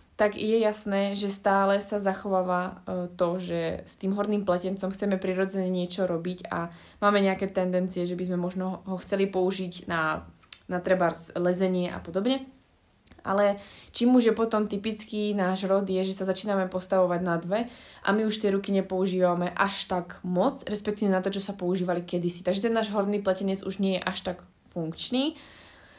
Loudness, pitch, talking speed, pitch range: -27 LUFS, 190 Hz, 180 wpm, 180-205 Hz